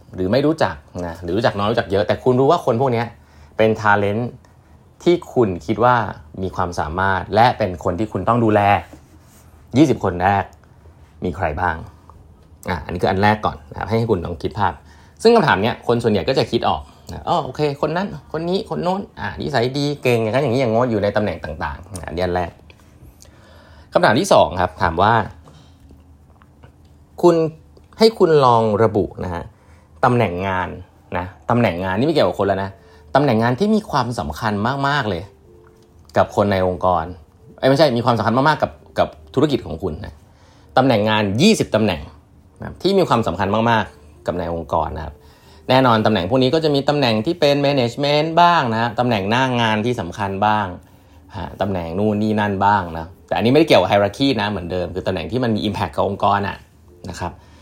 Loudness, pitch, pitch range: -18 LUFS, 105 Hz, 90-120 Hz